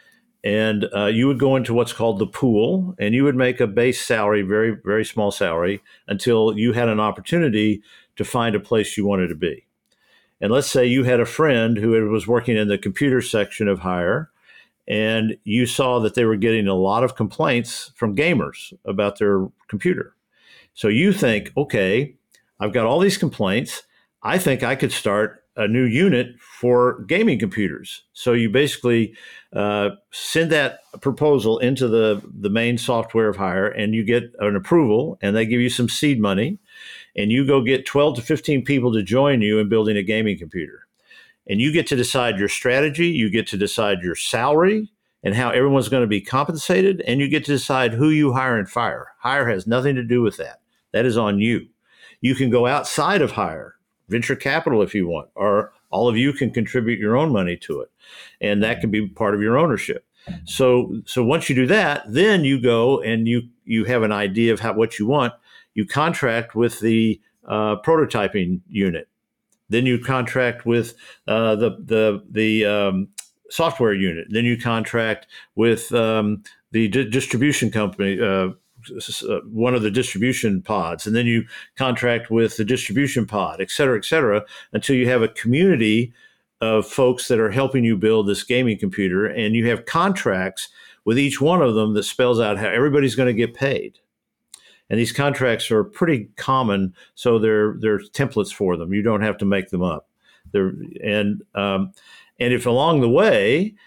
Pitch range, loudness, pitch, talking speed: 105-130 Hz, -20 LUFS, 115 Hz, 185 wpm